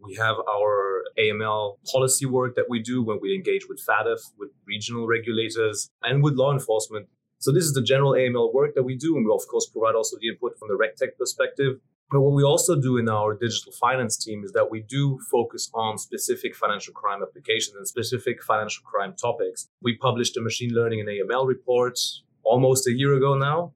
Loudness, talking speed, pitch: -24 LUFS, 205 wpm, 130 Hz